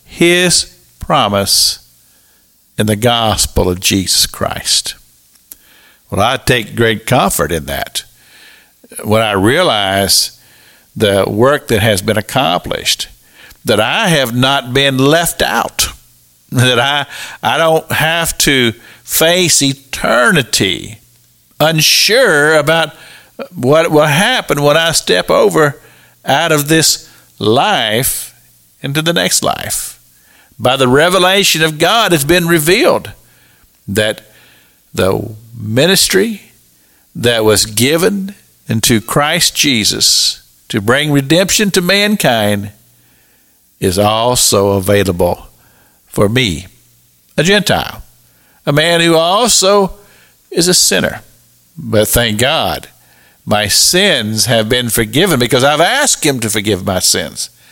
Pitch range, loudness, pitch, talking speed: 100-165 Hz, -11 LUFS, 125 Hz, 115 wpm